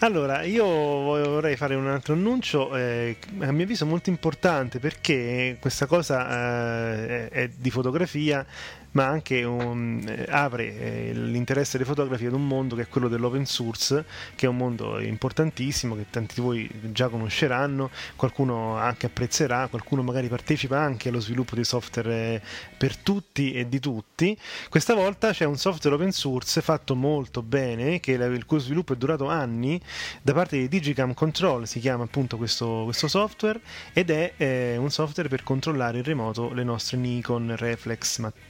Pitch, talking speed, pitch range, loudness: 130 Hz, 165 wpm, 120-150 Hz, -26 LUFS